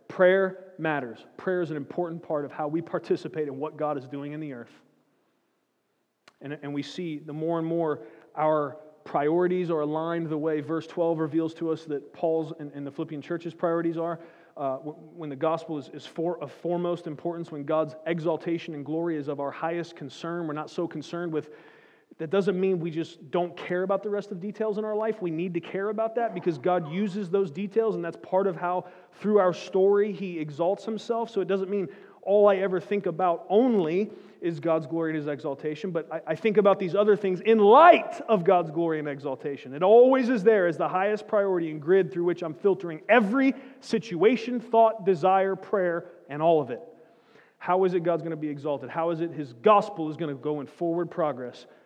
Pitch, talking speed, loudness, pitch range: 170 Hz, 210 wpm, -26 LUFS, 155-195 Hz